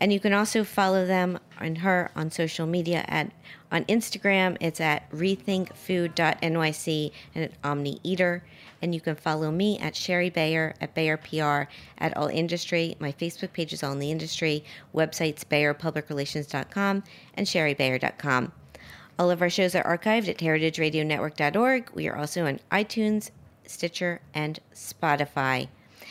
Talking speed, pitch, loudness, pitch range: 140 wpm, 165 Hz, -27 LUFS, 150-185 Hz